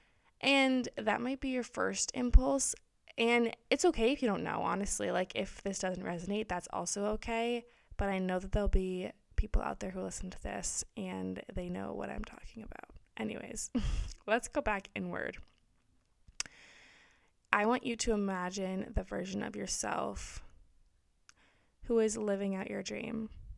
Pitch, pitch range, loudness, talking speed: 210 Hz, 185-240 Hz, -35 LUFS, 160 wpm